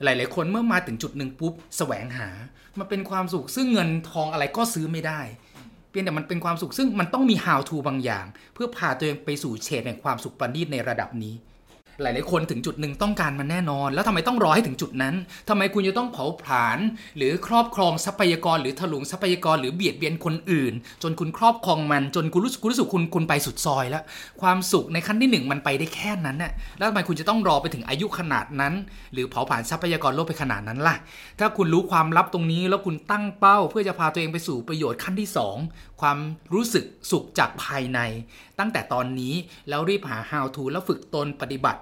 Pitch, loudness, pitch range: 165 Hz, -24 LUFS, 140-190 Hz